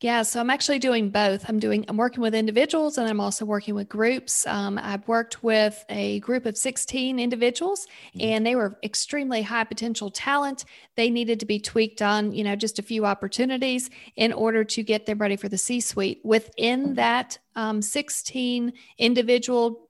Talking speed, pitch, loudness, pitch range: 185 wpm, 230 Hz, -24 LUFS, 210-245 Hz